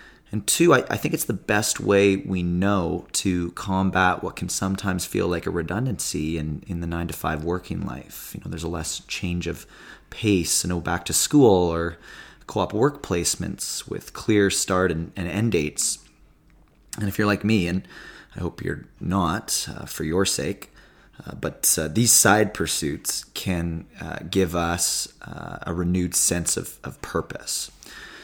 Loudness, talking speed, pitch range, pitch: -23 LUFS, 180 wpm, 85-100 Hz, 90 Hz